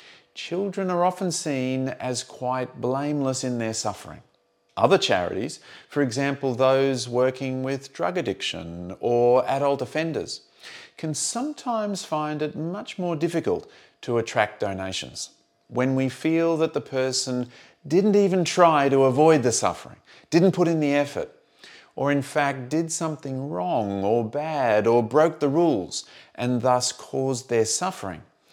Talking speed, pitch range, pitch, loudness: 140 wpm, 125-160 Hz, 135 Hz, -24 LUFS